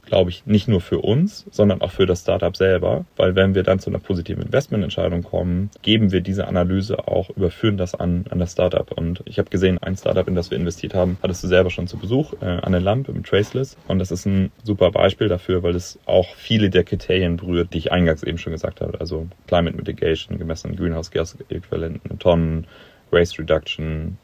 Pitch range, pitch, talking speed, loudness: 85-100 Hz, 95 Hz, 215 wpm, -21 LUFS